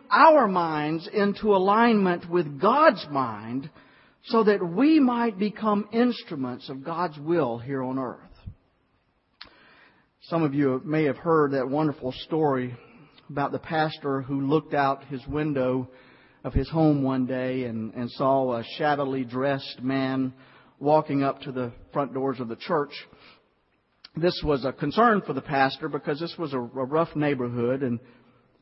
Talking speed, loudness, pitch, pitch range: 150 wpm, -25 LUFS, 140 Hz, 130-165 Hz